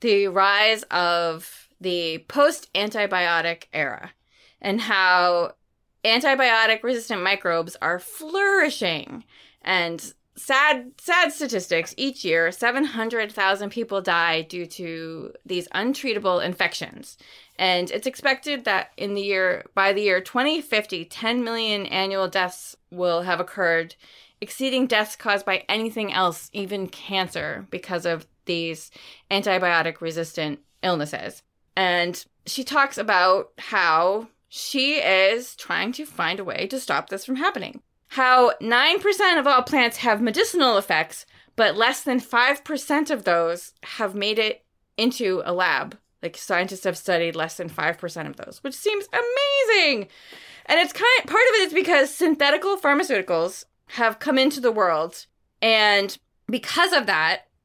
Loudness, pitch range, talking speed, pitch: -22 LUFS, 180-265 Hz, 135 wpm, 205 Hz